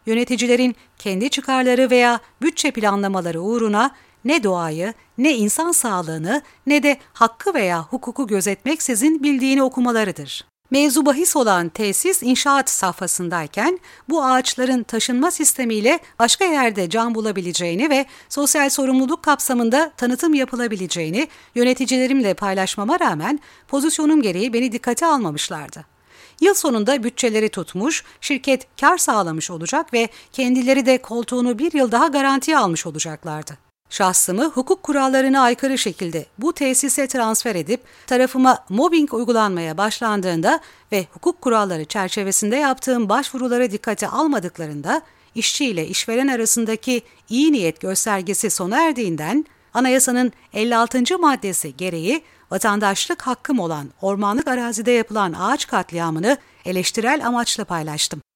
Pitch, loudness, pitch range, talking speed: 245 Hz, -19 LUFS, 200-275 Hz, 115 wpm